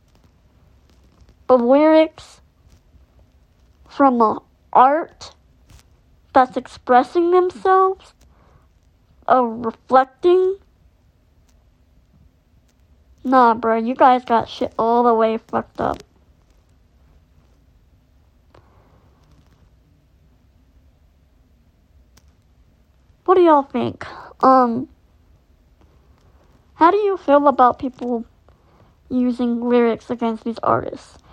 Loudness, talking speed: -17 LUFS, 75 wpm